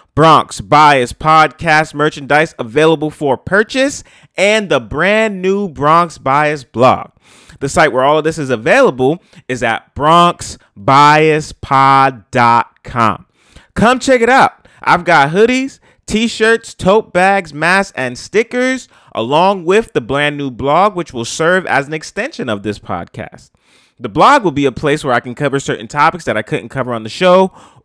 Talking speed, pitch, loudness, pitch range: 155 wpm, 150 Hz, -12 LUFS, 135-190 Hz